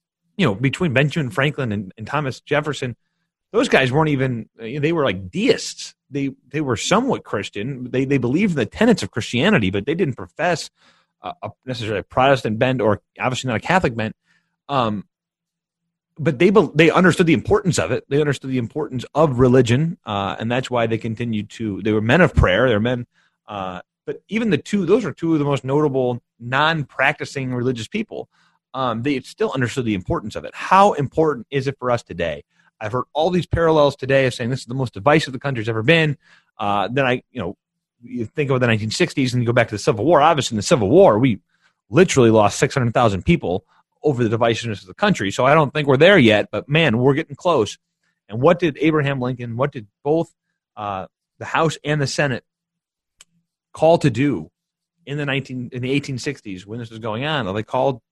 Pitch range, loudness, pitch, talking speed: 120-155 Hz, -19 LUFS, 135 Hz, 210 wpm